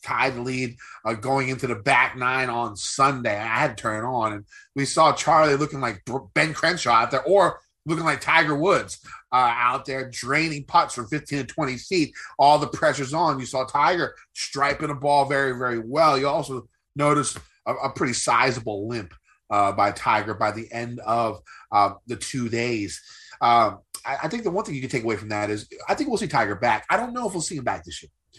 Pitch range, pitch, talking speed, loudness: 115-145 Hz, 130 Hz, 220 wpm, -23 LUFS